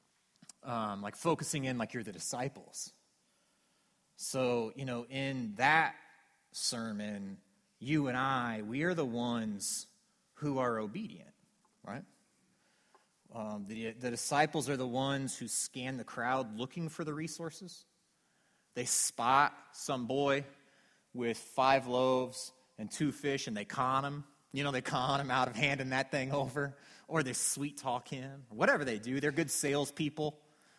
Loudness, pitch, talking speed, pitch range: -35 LUFS, 135 Hz, 150 wpm, 125-145 Hz